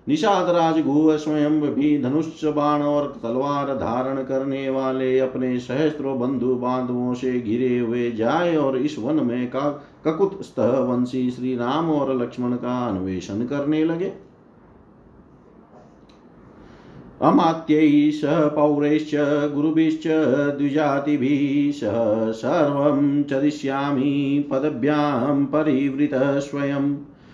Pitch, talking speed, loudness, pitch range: 140 Hz, 85 wpm, -21 LUFS, 130-150 Hz